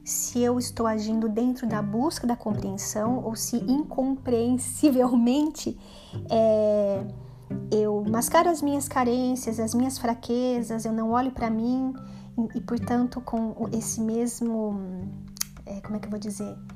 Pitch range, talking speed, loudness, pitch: 215-250 Hz, 140 wpm, -26 LUFS, 230 Hz